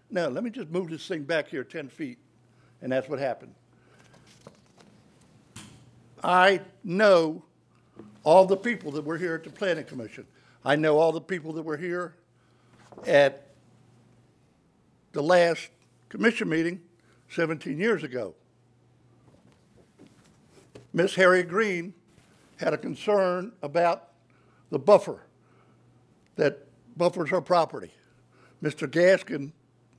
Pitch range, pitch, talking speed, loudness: 135-180 Hz, 165 Hz, 115 wpm, -25 LUFS